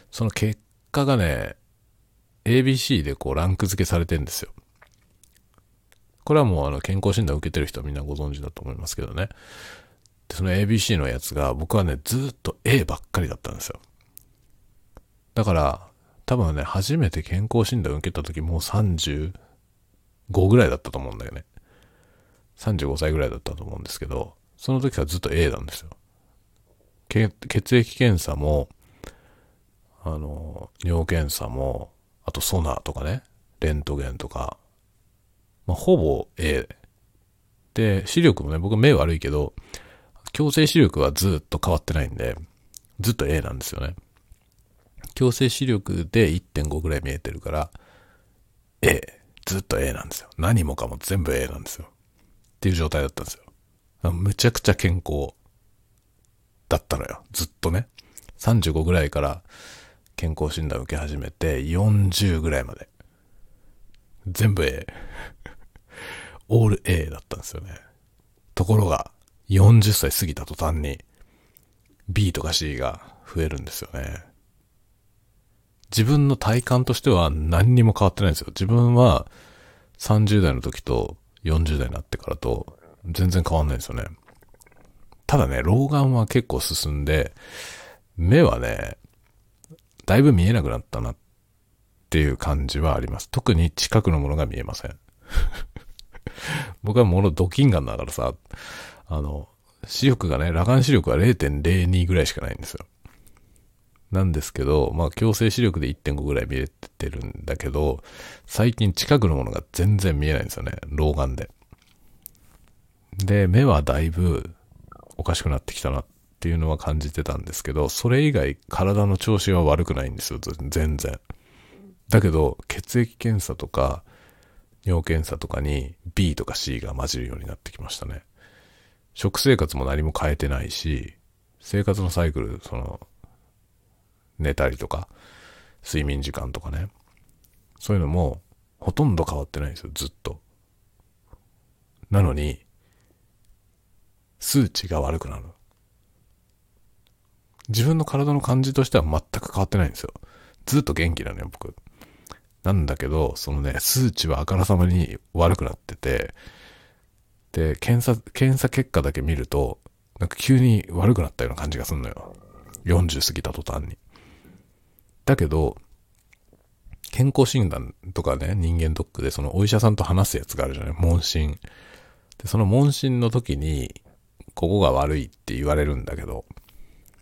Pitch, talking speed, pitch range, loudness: 95 Hz, 275 characters per minute, 80-110 Hz, -23 LUFS